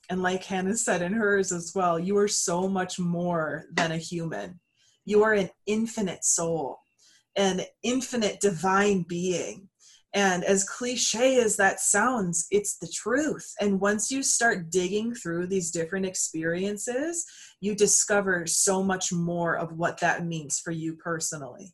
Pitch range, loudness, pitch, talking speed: 170-205 Hz, -26 LUFS, 190 Hz, 150 wpm